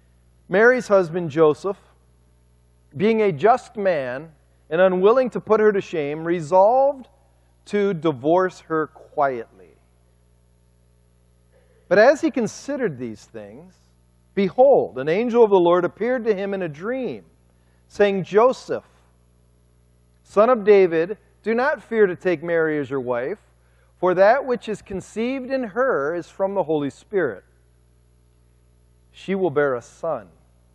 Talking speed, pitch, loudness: 135 wpm, 160 Hz, -20 LUFS